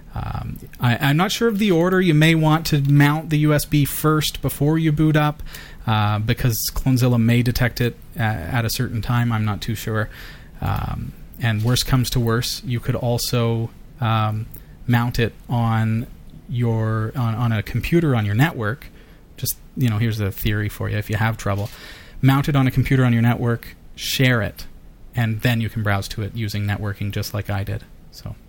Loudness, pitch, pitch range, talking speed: -20 LUFS, 120 Hz, 110-135 Hz, 195 wpm